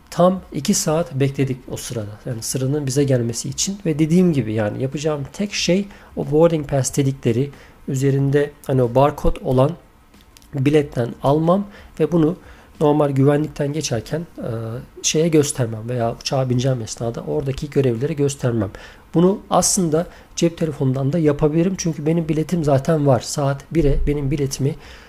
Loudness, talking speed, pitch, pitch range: -20 LUFS, 140 wpm, 145 Hz, 130-160 Hz